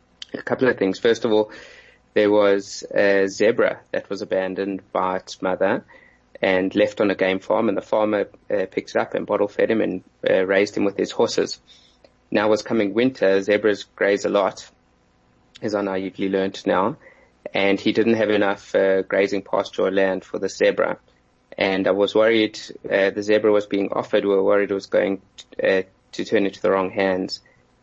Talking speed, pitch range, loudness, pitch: 200 wpm, 95-110 Hz, -21 LUFS, 100 Hz